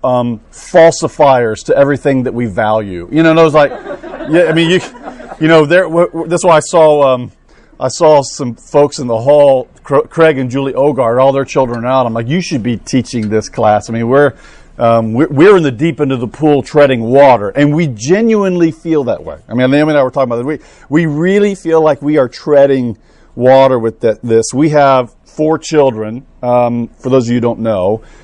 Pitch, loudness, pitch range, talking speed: 140 Hz, -11 LUFS, 120-155 Hz, 220 wpm